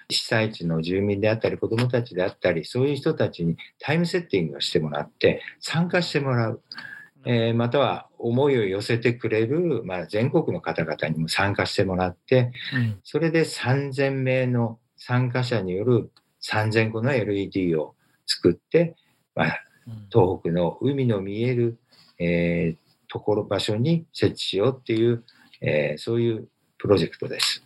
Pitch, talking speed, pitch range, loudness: 120 Hz, 310 characters per minute, 100-135 Hz, -24 LUFS